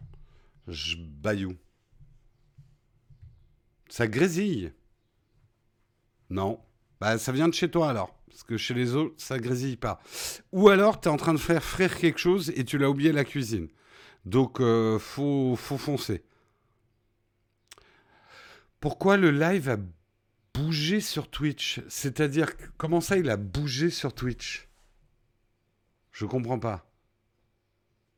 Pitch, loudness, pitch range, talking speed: 125 Hz, -27 LUFS, 115-150 Hz, 130 wpm